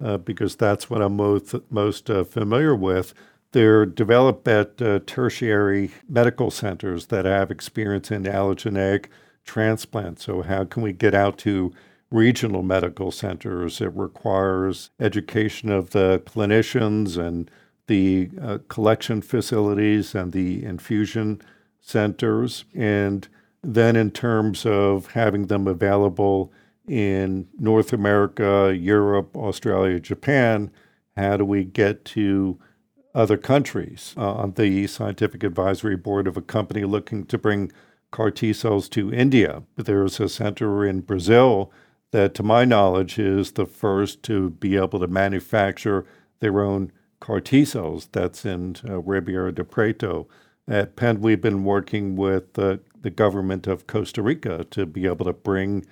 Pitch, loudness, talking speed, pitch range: 100 Hz, -22 LUFS, 140 wpm, 95-110 Hz